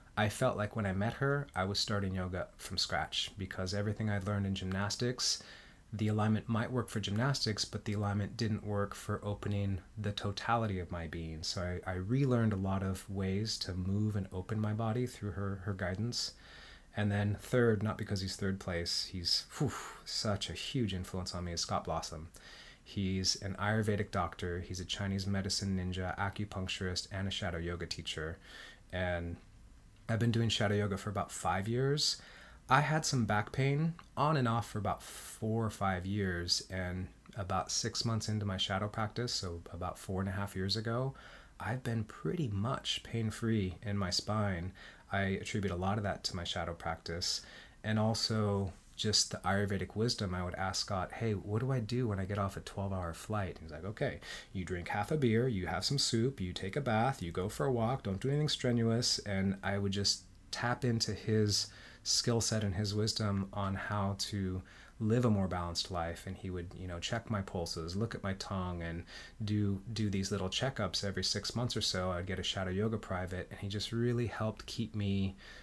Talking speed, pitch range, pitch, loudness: 200 wpm, 95-110 Hz, 100 Hz, -35 LUFS